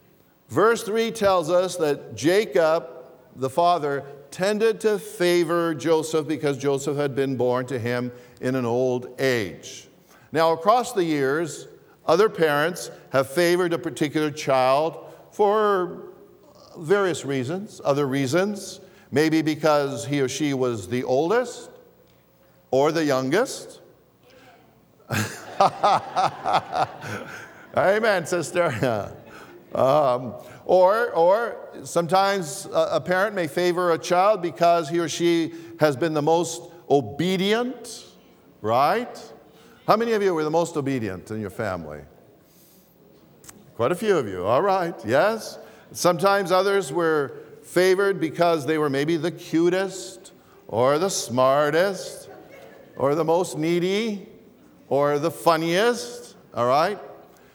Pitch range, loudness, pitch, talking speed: 140-185 Hz, -23 LUFS, 165 Hz, 120 wpm